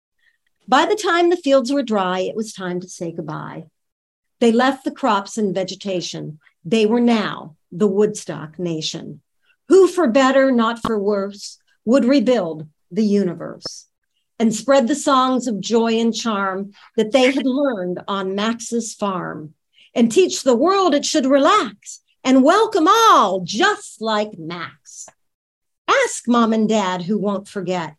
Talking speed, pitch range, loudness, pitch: 150 wpm, 195-275 Hz, -18 LUFS, 225 Hz